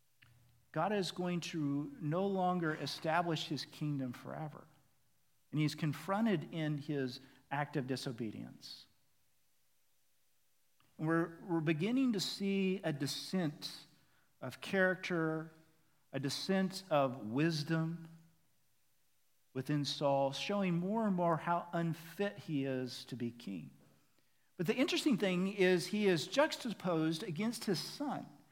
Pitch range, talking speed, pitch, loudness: 140-185 Hz, 120 wpm, 160 Hz, -37 LUFS